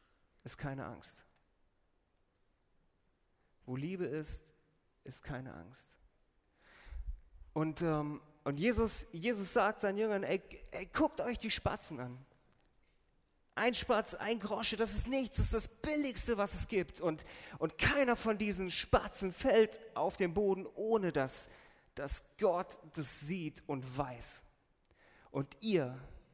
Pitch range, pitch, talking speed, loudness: 135-220 Hz, 175 Hz, 130 wpm, -36 LUFS